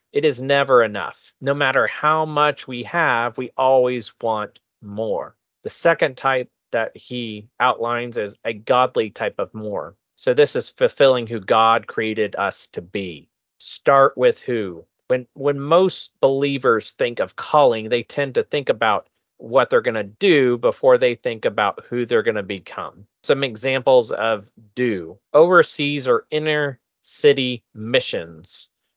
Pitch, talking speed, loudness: 135 Hz, 155 wpm, -19 LUFS